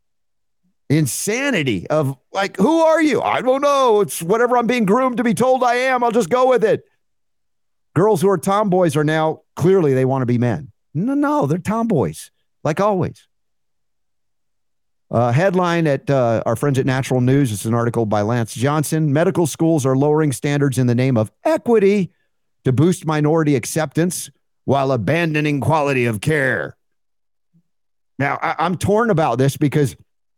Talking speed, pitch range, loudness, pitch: 165 wpm, 135-205 Hz, -17 LUFS, 155 Hz